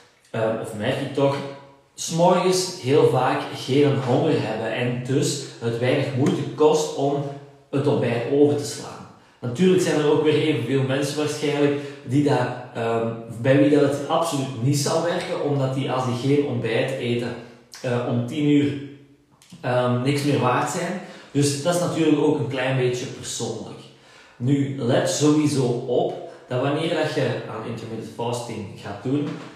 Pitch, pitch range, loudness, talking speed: 140 Hz, 125-150 Hz, -22 LUFS, 160 wpm